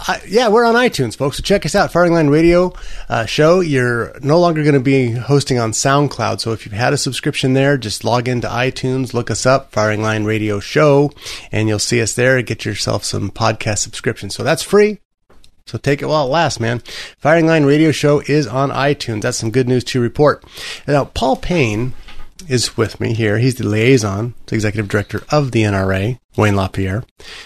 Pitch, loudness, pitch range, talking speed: 125 Hz, -15 LUFS, 110-145 Hz, 205 wpm